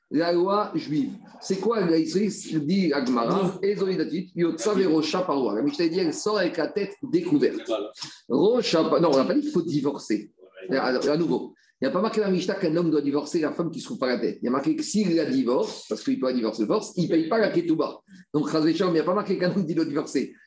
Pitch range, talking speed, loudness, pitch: 155-210 Hz, 275 wpm, -25 LUFS, 175 Hz